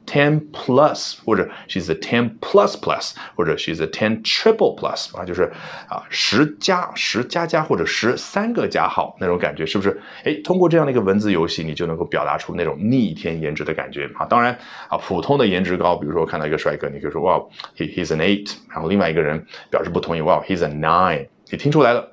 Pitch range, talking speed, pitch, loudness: 85-145 Hz, 430 characters per minute, 100 Hz, -20 LUFS